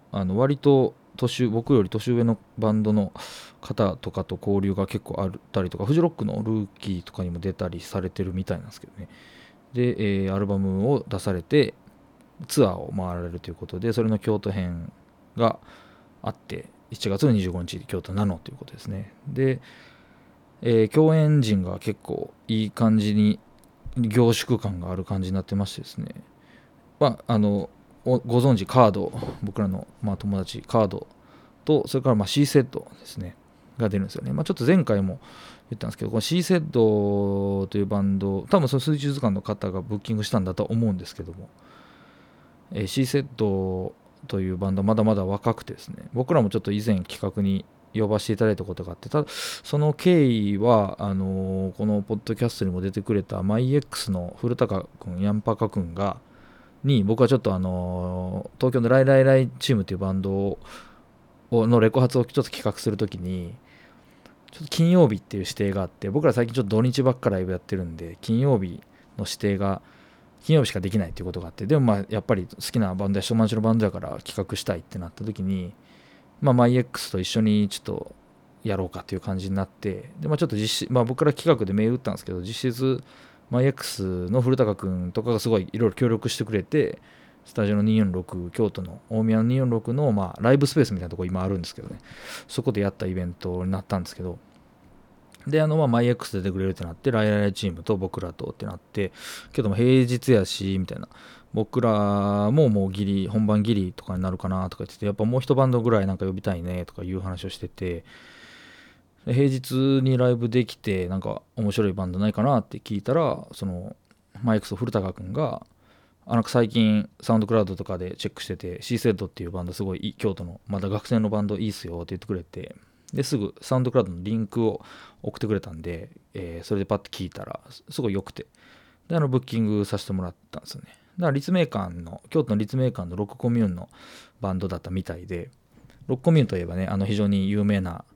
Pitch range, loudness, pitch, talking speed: 95-120 Hz, -25 LUFS, 105 Hz, 405 characters per minute